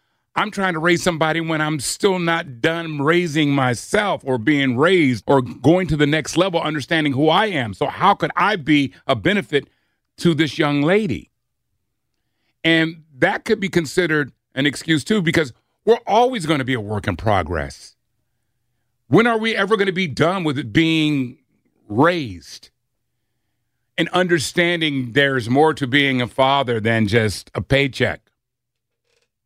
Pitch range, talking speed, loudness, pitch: 120-165 Hz, 160 wpm, -18 LUFS, 145 Hz